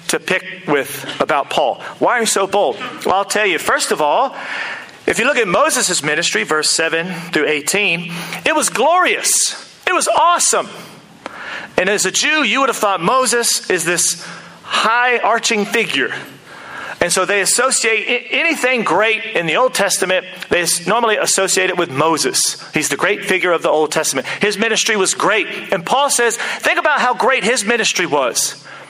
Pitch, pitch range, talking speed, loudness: 200 Hz, 175-240 Hz, 175 wpm, -15 LUFS